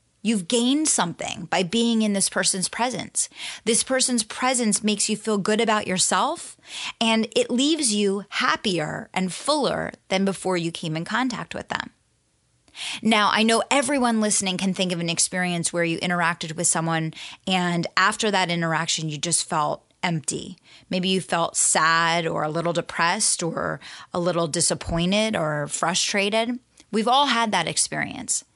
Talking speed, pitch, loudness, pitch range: 160 wpm, 190 Hz, -22 LUFS, 170-225 Hz